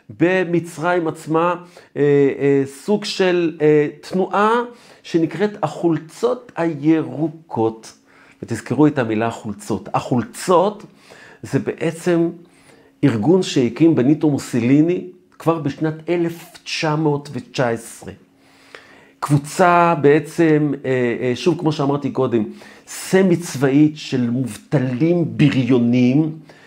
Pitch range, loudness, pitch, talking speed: 135-170 Hz, -18 LUFS, 150 Hz, 85 wpm